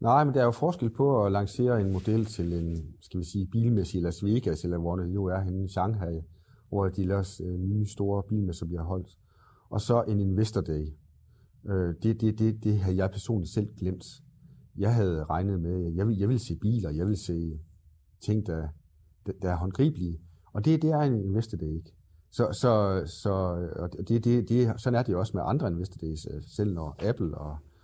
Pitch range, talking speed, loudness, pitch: 85-110 Hz, 210 wpm, -29 LUFS, 95 Hz